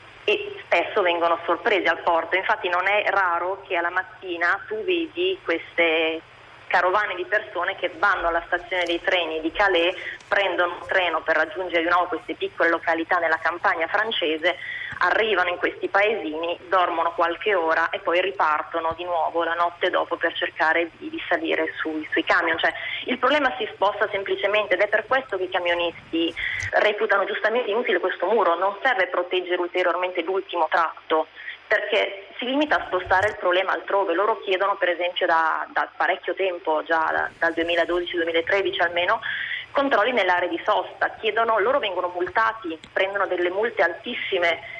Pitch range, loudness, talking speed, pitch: 170-200 Hz, -23 LUFS, 160 wpm, 180 Hz